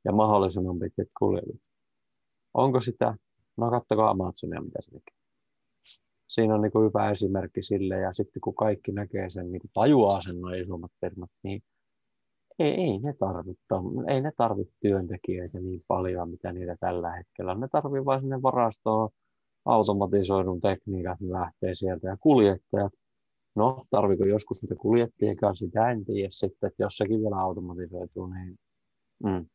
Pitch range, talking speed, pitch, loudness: 90-110 Hz, 160 wpm, 100 Hz, -28 LUFS